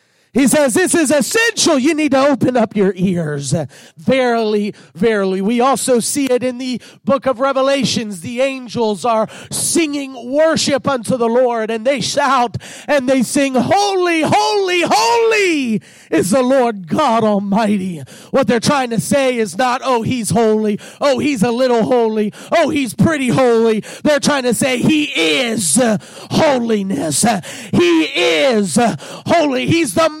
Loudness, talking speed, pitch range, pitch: -15 LUFS, 150 wpm, 215-280 Hz, 250 Hz